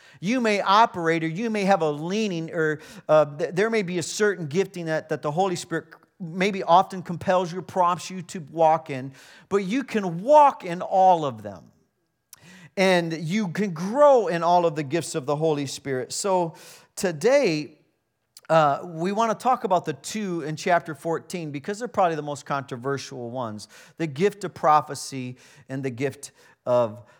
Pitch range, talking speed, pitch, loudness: 150-190 Hz, 175 wpm, 170 Hz, -24 LUFS